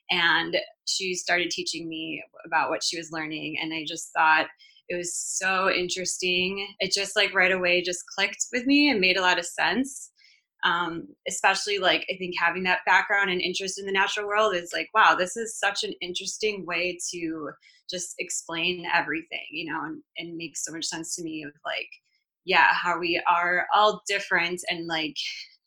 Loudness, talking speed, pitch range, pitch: -25 LUFS, 190 wpm, 170-210 Hz, 185 Hz